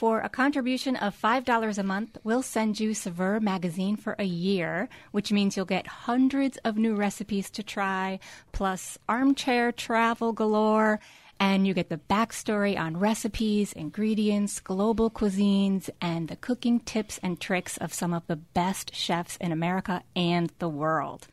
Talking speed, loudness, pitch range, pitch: 160 wpm, -27 LUFS, 185-225 Hz, 205 Hz